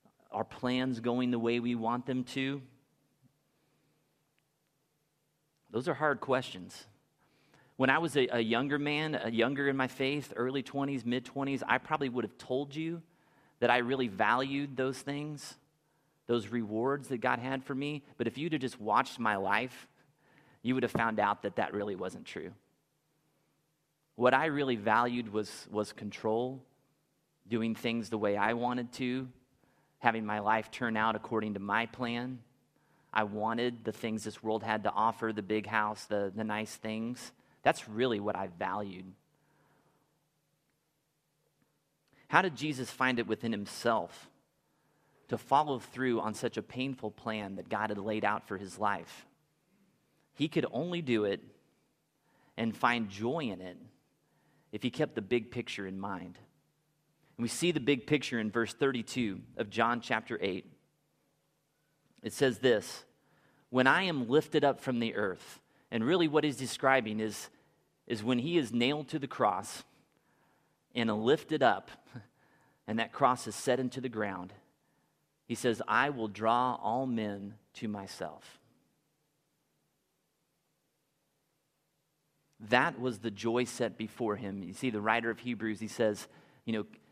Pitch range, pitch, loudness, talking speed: 110-140 Hz, 125 Hz, -33 LUFS, 155 wpm